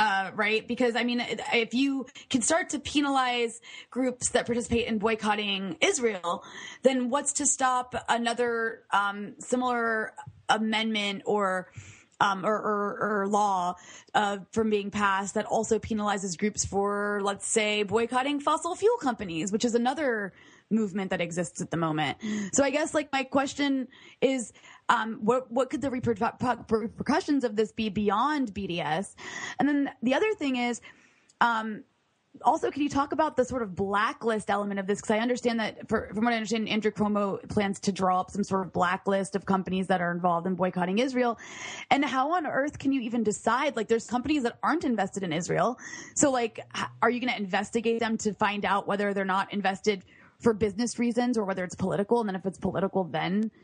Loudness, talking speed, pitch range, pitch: -28 LUFS, 185 wpm, 200-245 Hz, 220 Hz